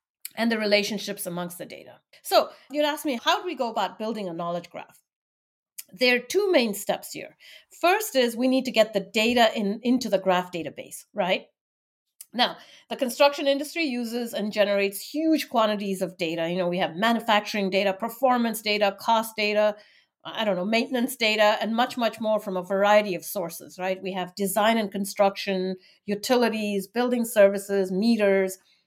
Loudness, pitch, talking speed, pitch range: -24 LUFS, 210 Hz, 175 wpm, 195-245 Hz